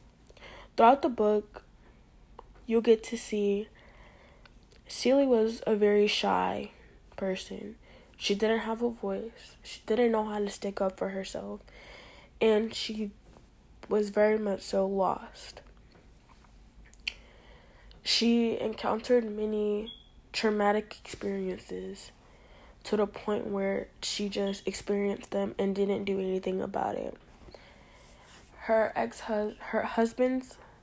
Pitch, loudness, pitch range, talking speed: 210 Hz, -30 LUFS, 200-225 Hz, 110 wpm